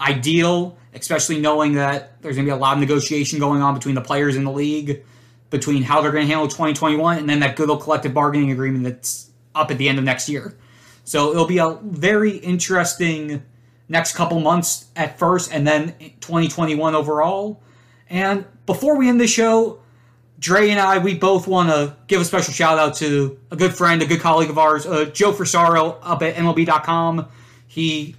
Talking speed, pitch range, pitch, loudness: 195 wpm, 140-170 Hz, 155 Hz, -18 LUFS